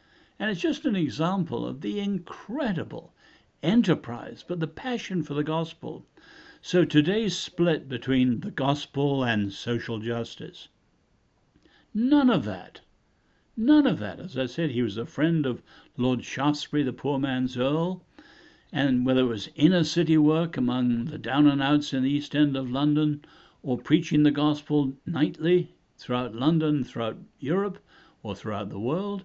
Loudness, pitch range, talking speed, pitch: -26 LUFS, 125-170 Hz, 155 wpm, 150 Hz